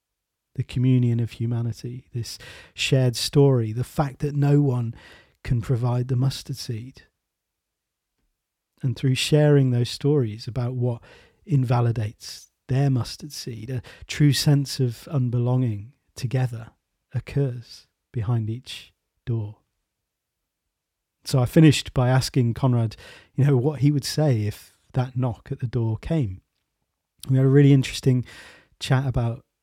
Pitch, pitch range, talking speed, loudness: 125 Hz, 115-135 Hz, 130 wpm, -23 LUFS